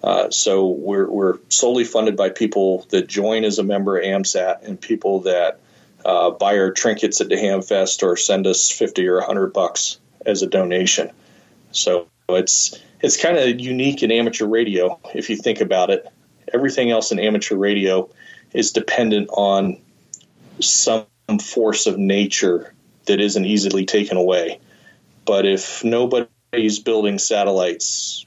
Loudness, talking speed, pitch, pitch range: -18 LUFS, 150 wpm, 100 Hz, 95-110 Hz